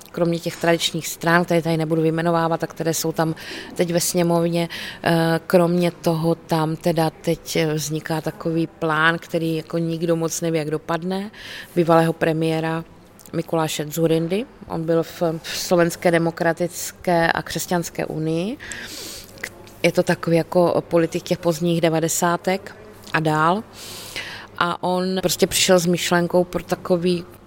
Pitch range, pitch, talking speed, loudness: 165-175 Hz, 170 Hz, 130 wpm, -21 LUFS